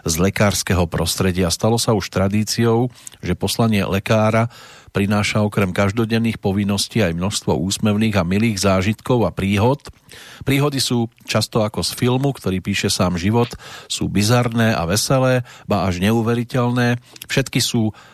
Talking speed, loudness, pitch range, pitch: 135 wpm, -19 LUFS, 100-120 Hz, 110 Hz